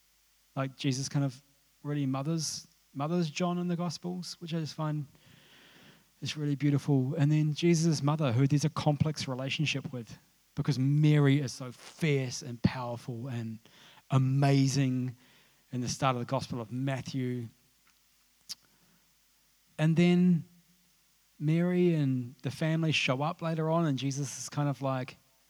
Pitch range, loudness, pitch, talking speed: 130-160 Hz, -30 LUFS, 145 Hz, 145 wpm